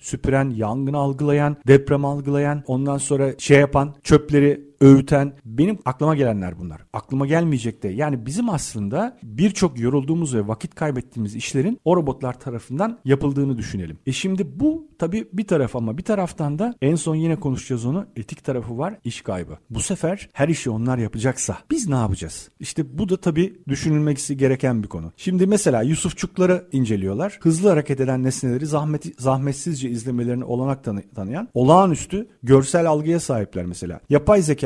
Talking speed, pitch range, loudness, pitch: 155 wpm, 125-165 Hz, -21 LUFS, 140 Hz